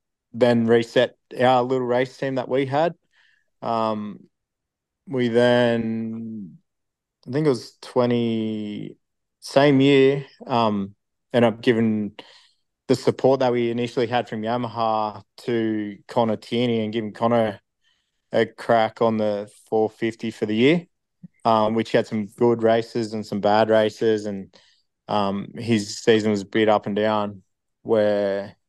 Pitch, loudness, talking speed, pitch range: 115 Hz, -22 LUFS, 140 wpm, 105-120 Hz